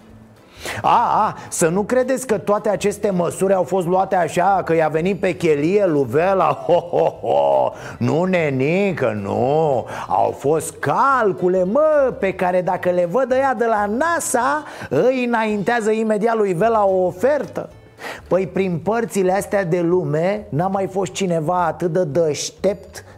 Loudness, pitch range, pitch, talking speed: -18 LUFS, 175-215 Hz, 190 Hz, 155 wpm